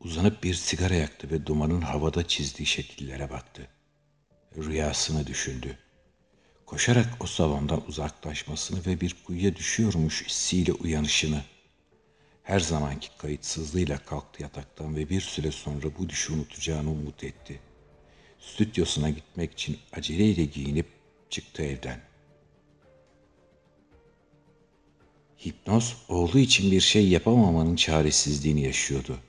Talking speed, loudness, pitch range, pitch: 105 wpm, -27 LUFS, 75-90 Hz, 80 Hz